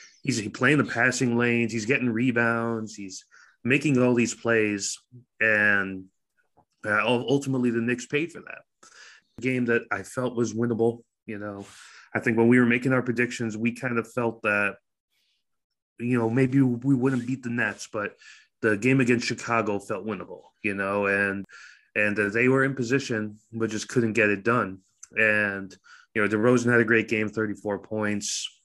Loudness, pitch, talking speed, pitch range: -25 LUFS, 115 Hz, 170 wpm, 105-125 Hz